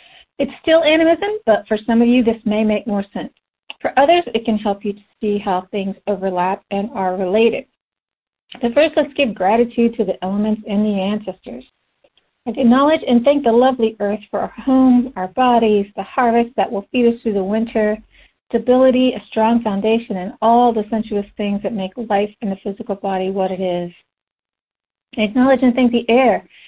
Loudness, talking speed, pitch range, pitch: -17 LUFS, 185 wpm, 200-250 Hz, 220 Hz